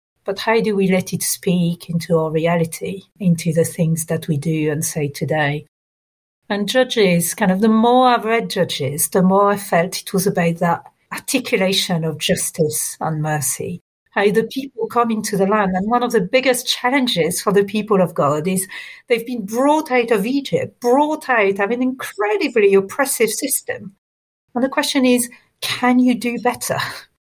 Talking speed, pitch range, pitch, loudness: 175 wpm, 170-245 Hz, 200 Hz, -18 LUFS